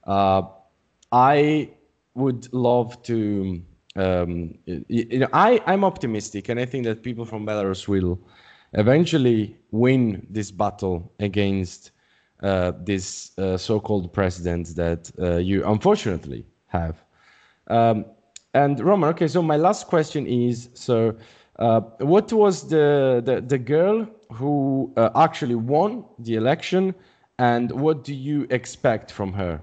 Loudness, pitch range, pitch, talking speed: -22 LUFS, 95-145 Hz, 115 Hz, 130 wpm